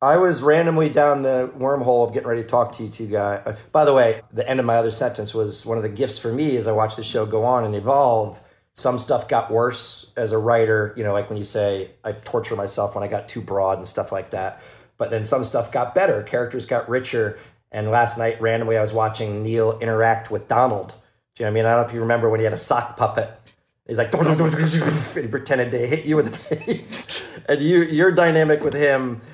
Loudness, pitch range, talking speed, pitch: -21 LUFS, 110-135 Hz, 250 wpm, 115 Hz